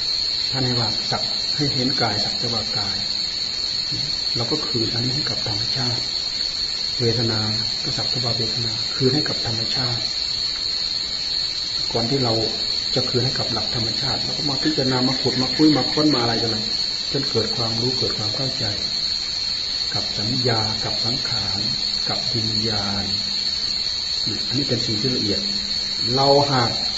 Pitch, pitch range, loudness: 115 Hz, 110-130 Hz, -20 LUFS